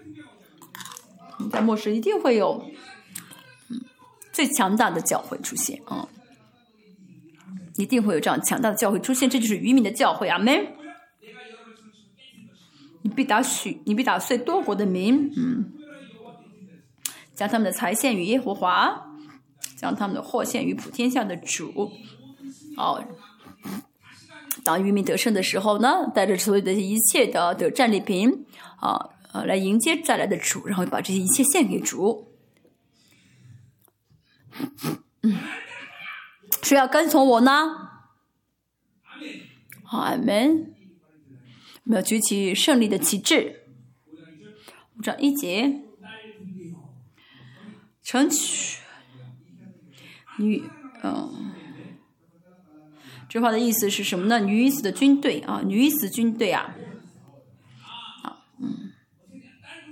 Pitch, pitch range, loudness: 220 Hz, 190-260 Hz, -23 LUFS